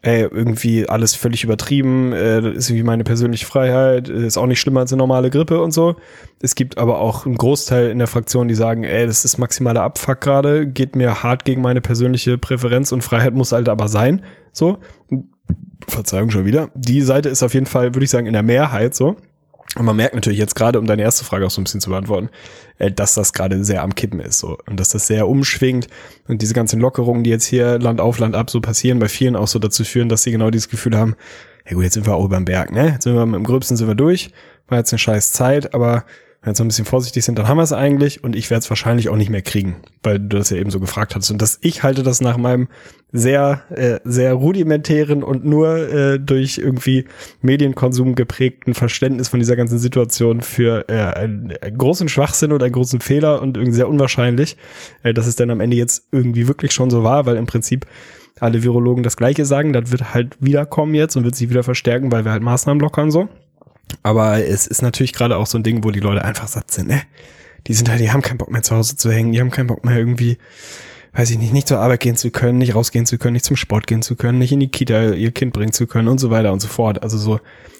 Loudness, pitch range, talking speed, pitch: -16 LUFS, 115-130 Hz, 245 wpm, 120 Hz